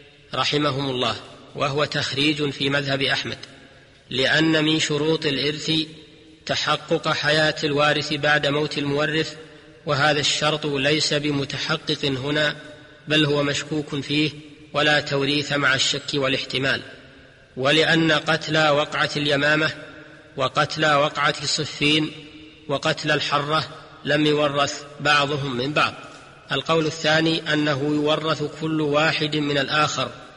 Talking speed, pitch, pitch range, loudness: 105 wpm, 150 Hz, 145-155 Hz, -21 LUFS